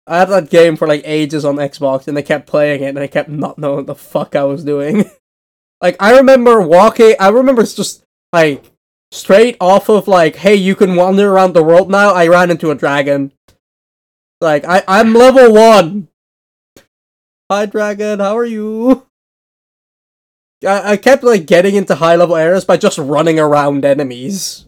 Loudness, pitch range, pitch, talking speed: -10 LUFS, 145-205 Hz, 175 Hz, 180 wpm